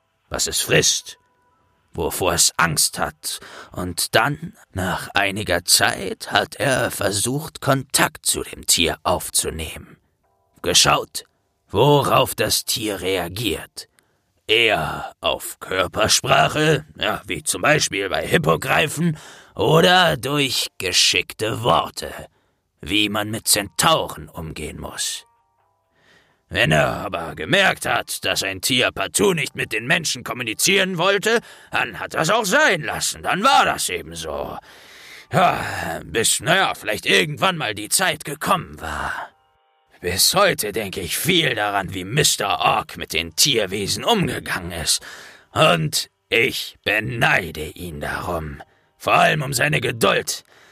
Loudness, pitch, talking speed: -19 LUFS, 115 Hz, 125 wpm